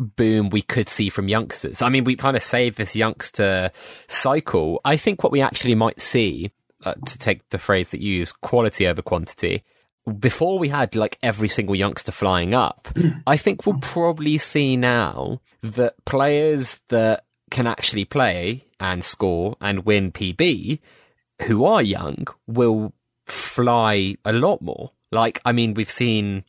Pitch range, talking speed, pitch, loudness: 100-130 Hz, 165 wpm, 110 Hz, -20 LUFS